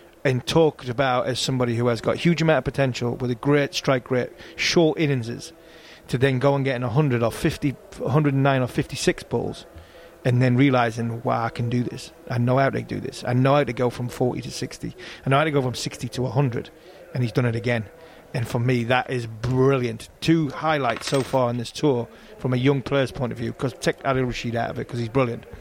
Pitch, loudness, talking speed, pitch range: 130 Hz, -23 LUFS, 235 wpm, 120-145 Hz